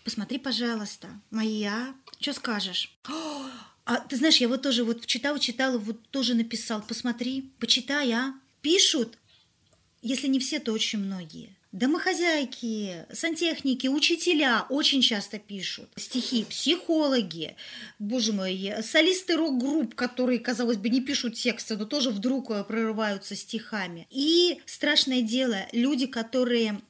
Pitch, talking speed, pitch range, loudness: 245 Hz, 125 wpm, 220-275 Hz, -26 LUFS